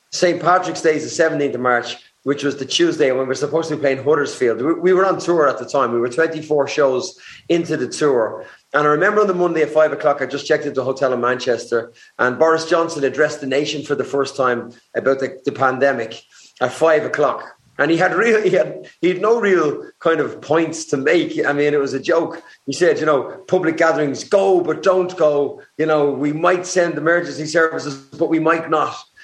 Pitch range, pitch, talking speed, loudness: 140-170 Hz, 155 Hz, 225 wpm, -18 LUFS